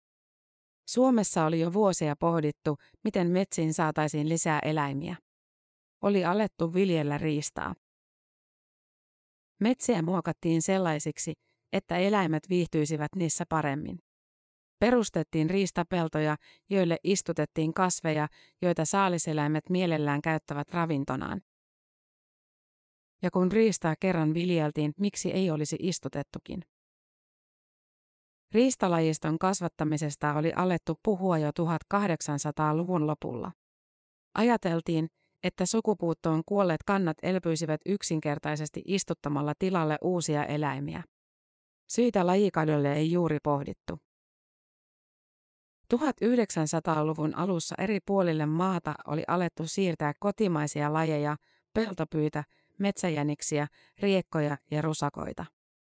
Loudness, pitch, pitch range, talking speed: -29 LUFS, 165 Hz, 155-185 Hz, 85 wpm